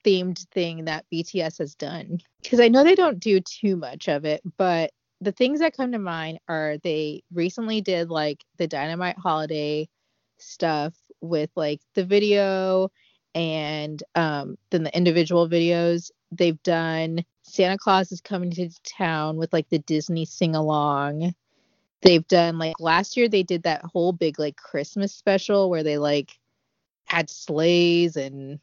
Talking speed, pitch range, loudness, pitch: 155 wpm, 155-185 Hz, -23 LUFS, 170 Hz